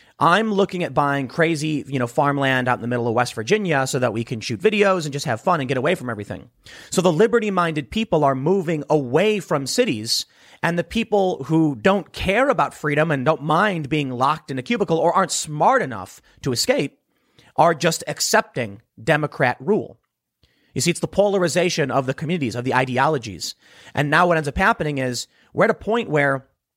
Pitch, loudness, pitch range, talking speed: 155 Hz, -20 LUFS, 135-180 Hz, 200 wpm